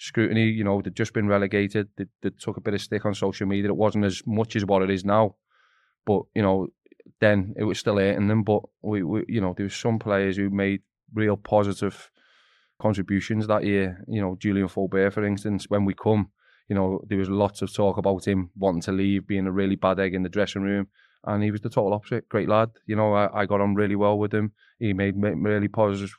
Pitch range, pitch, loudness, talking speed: 100-105 Hz, 100 Hz, -25 LUFS, 235 wpm